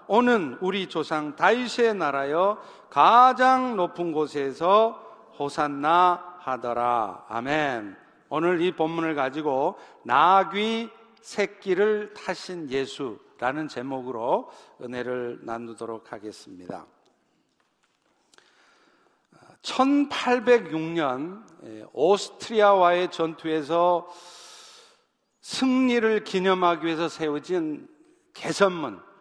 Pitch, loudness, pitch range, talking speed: 180 Hz, -24 LUFS, 155-225 Hz, 185 characters per minute